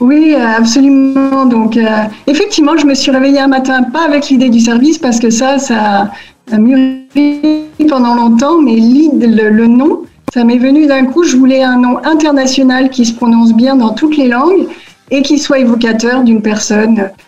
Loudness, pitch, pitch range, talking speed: -9 LUFS, 260 Hz, 235-285 Hz, 185 wpm